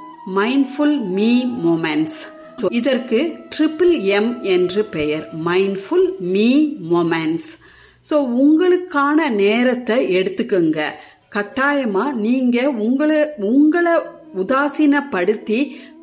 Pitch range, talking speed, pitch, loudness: 195-300 Hz, 65 wpm, 250 Hz, -17 LUFS